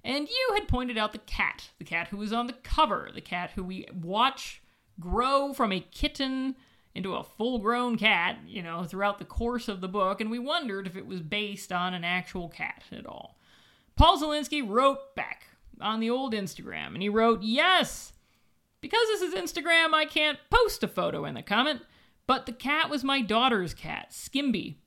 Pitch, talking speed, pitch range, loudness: 235 Hz, 195 wpm, 200-295 Hz, -28 LUFS